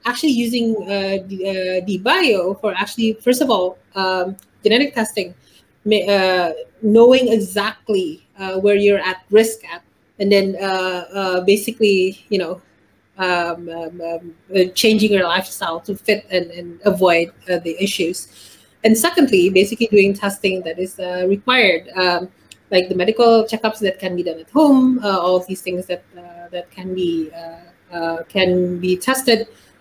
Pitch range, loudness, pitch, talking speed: 180-215 Hz, -17 LUFS, 190 Hz, 165 wpm